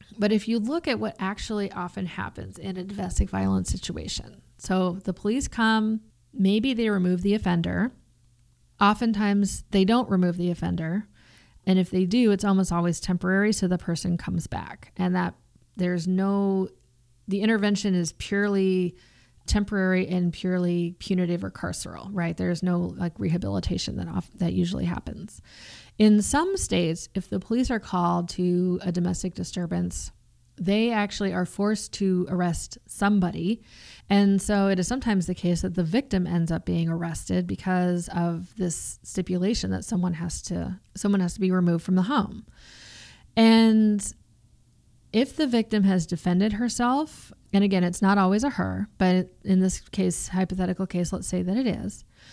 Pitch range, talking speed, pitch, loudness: 170-205 Hz, 160 wpm, 185 Hz, -25 LUFS